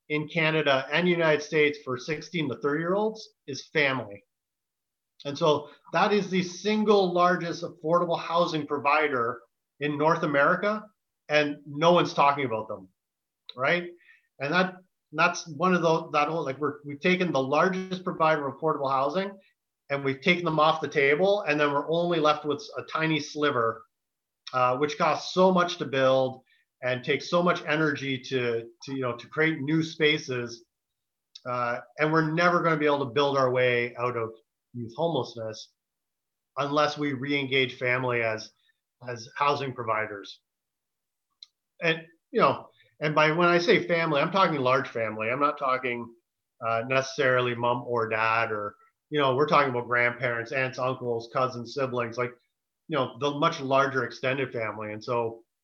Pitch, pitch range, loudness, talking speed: 145 Hz, 125-160 Hz, -26 LUFS, 165 wpm